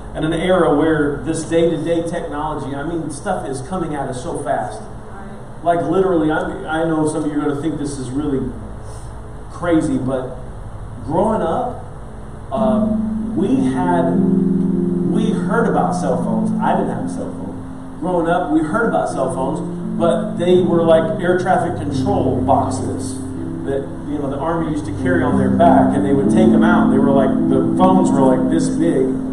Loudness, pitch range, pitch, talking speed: -17 LUFS, 125-180 Hz, 160 Hz, 180 wpm